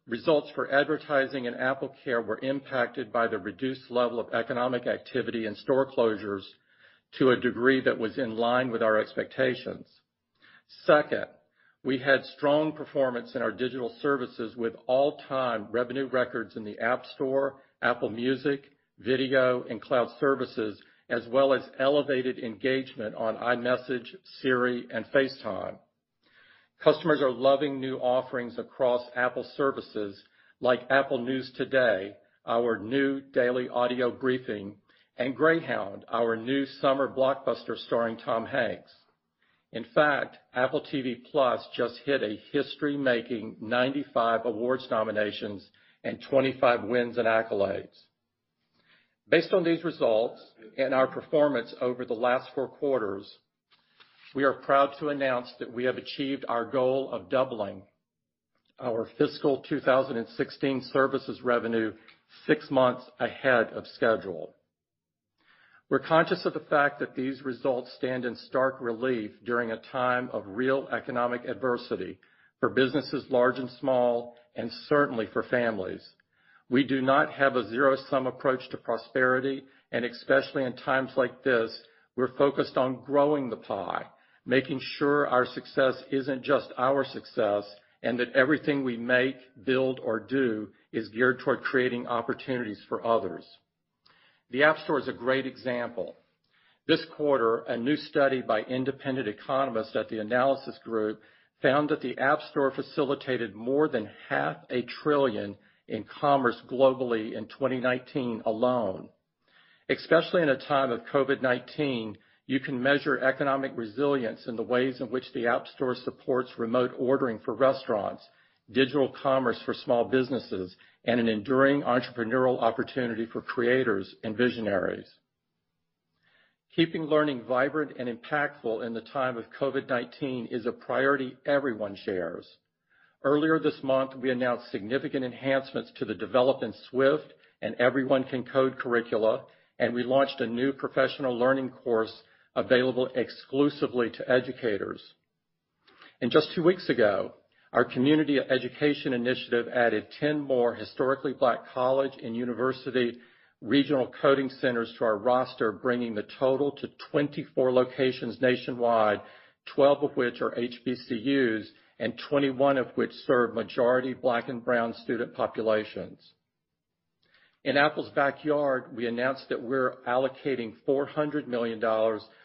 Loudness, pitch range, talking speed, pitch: -28 LUFS, 120-135 Hz, 135 wpm, 130 Hz